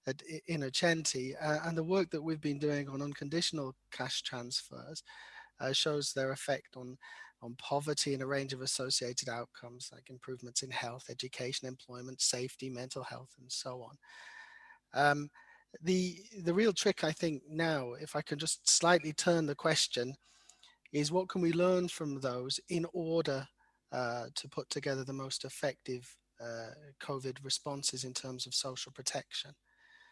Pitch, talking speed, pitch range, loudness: 140 Hz, 155 wpm, 130-165 Hz, -35 LUFS